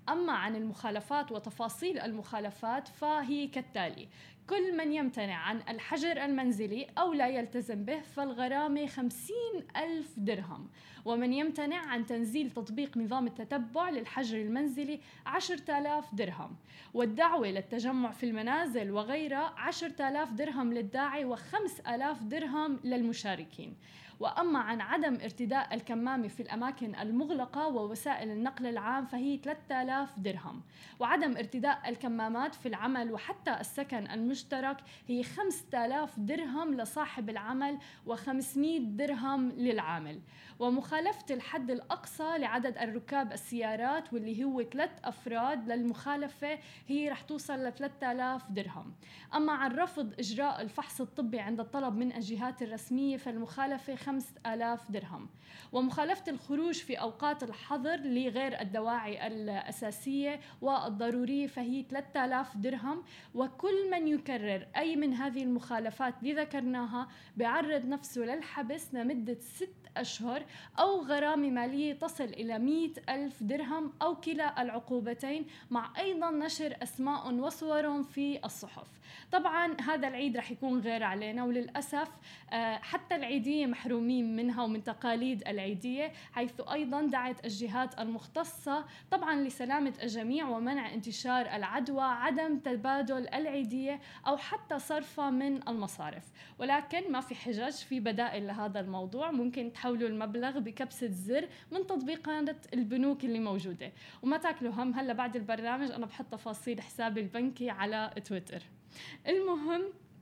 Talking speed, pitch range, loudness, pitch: 120 wpm, 235-290 Hz, -35 LUFS, 260 Hz